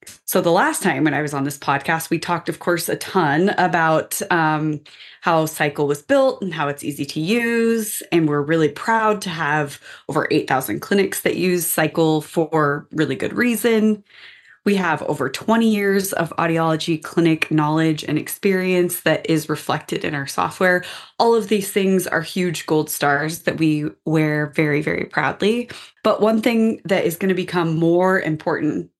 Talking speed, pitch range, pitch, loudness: 175 wpm, 155-190 Hz, 165 Hz, -19 LUFS